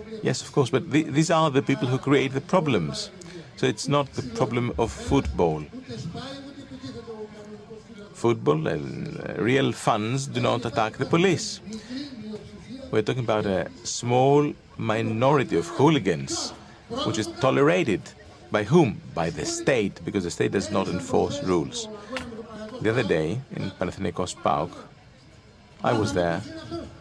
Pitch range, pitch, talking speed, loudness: 130-215 Hz, 150 Hz, 140 wpm, -25 LUFS